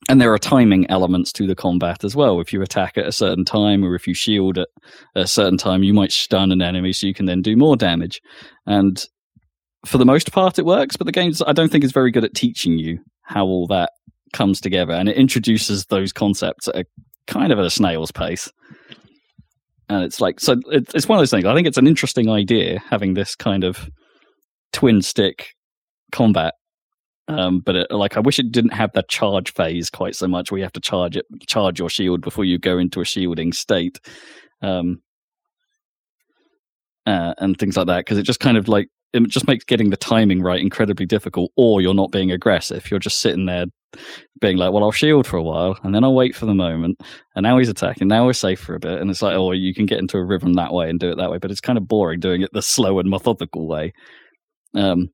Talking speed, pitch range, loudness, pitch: 230 wpm, 90-115 Hz, -18 LUFS, 95 Hz